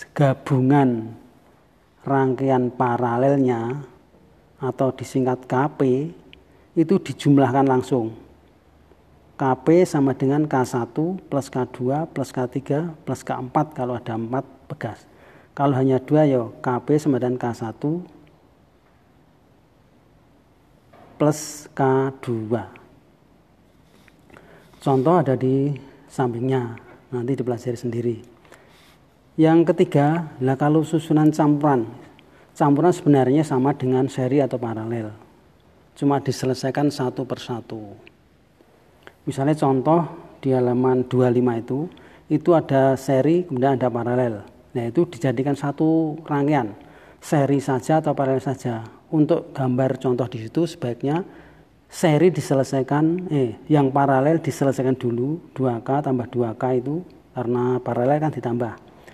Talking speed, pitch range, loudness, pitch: 100 wpm, 125-145 Hz, -21 LUFS, 135 Hz